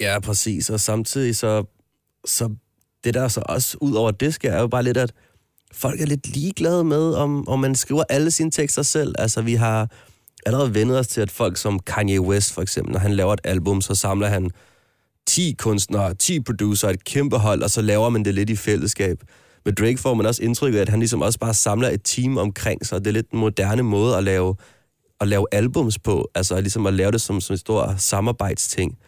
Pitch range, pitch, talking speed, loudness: 100-125 Hz, 110 Hz, 225 wpm, -21 LUFS